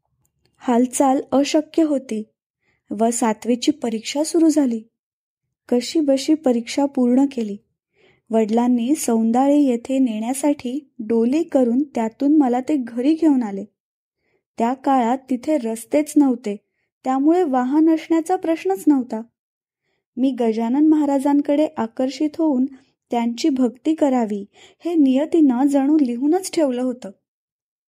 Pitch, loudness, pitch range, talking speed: 265 Hz, -19 LUFS, 235-300 Hz, 105 wpm